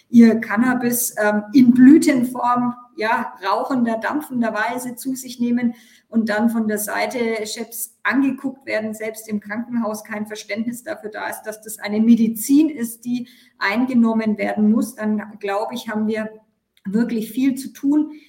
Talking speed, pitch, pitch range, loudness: 150 wpm, 230 Hz, 215-245 Hz, -19 LUFS